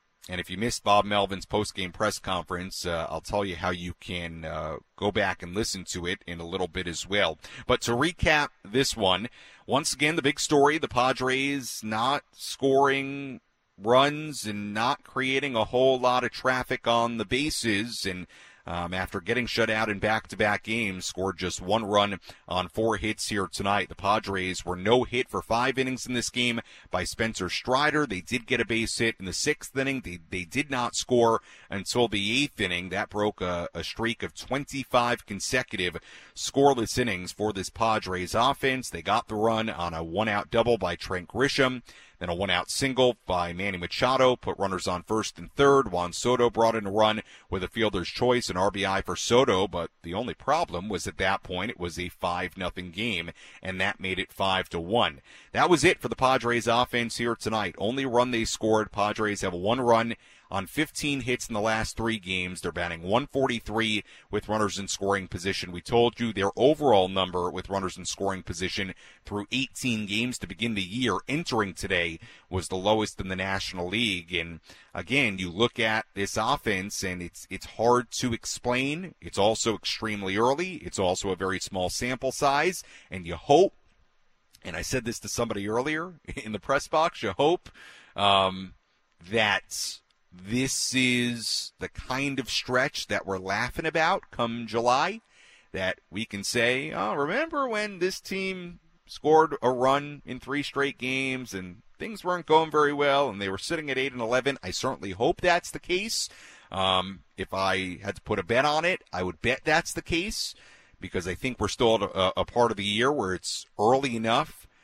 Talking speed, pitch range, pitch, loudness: 190 wpm, 95-125 Hz, 110 Hz, -27 LUFS